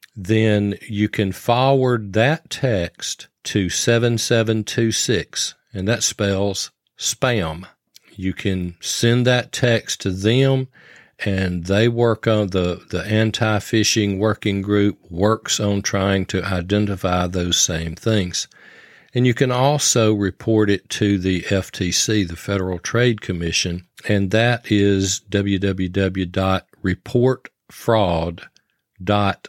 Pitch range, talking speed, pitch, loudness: 95-115 Hz, 110 wpm, 105 Hz, -19 LUFS